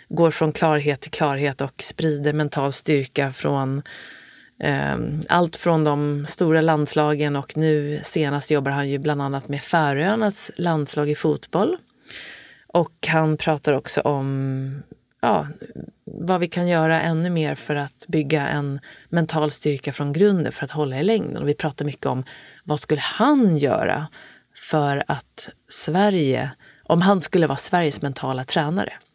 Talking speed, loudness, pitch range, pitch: 150 wpm, -21 LUFS, 145-170 Hz, 150 Hz